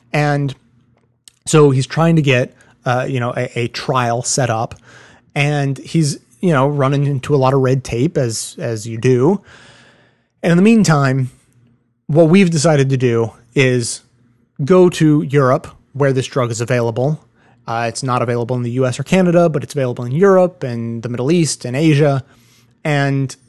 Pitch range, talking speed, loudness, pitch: 120-150 Hz, 175 wpm, -15 LUFS, 130 Hz